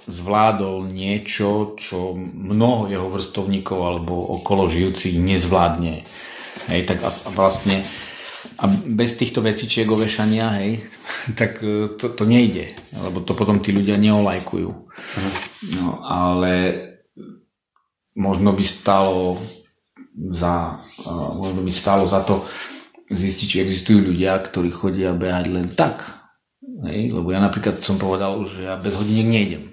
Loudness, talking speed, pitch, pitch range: -20 LUFS, 125 wpm, 95 Hz, 90-105 Hz